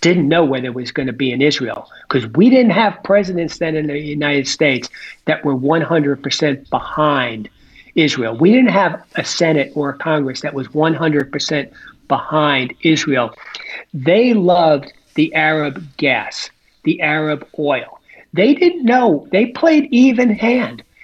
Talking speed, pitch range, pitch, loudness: 150 wpm, 140-180 Hz, 155 Hz, -15 LUFS